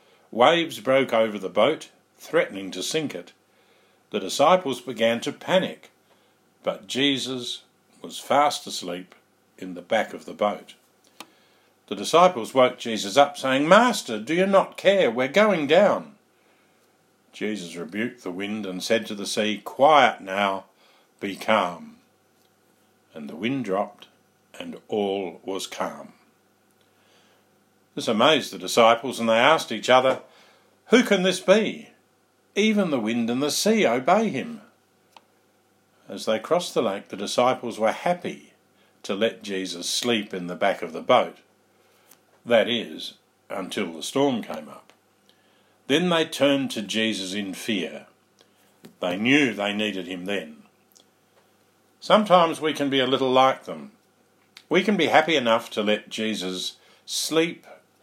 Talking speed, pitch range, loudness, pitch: 140 wpm, 100-145 Hz, -23 LUFS, 120 Hz